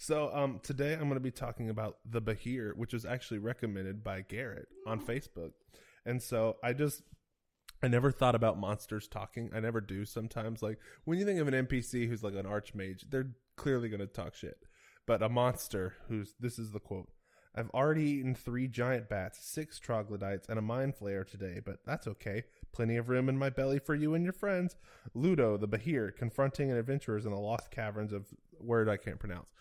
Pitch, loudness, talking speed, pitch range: 115 Hz, -36 LUFS, 205 wpm, 105-130 Hz